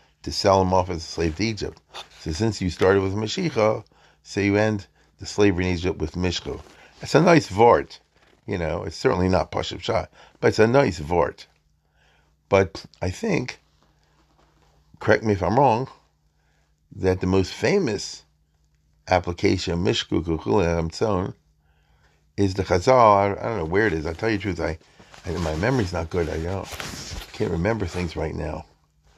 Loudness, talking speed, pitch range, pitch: -23 LUFS, 170 wpm, 75-100 Hz, 90 Hz